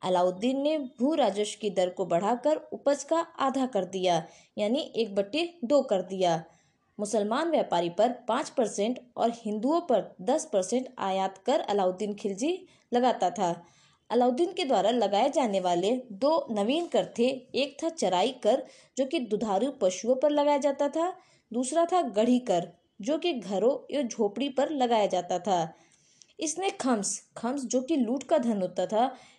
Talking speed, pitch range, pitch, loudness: 165 wpm, 195-285 Hz, 235 Hz, -28 LUFS